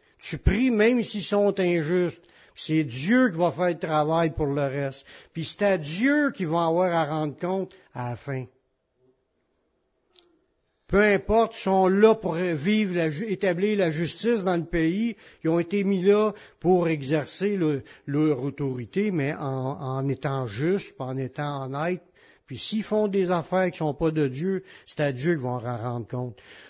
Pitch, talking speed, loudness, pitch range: 170 Hz, 180 wpm, -25 LUFS, 145-195 Hz